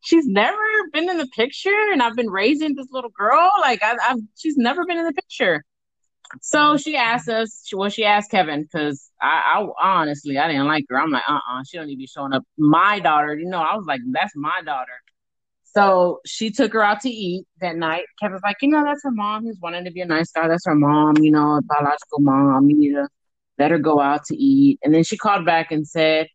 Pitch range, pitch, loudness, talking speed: 150-255 Hz, 195 Hz, -19 LUFS, 240 wpm